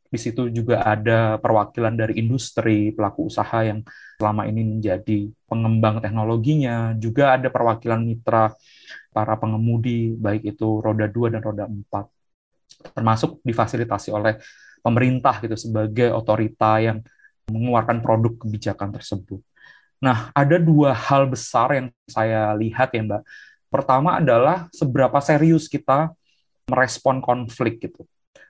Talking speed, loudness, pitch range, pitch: 120 wpm, -21 LUFS, 110-130 Hz, 115 Hz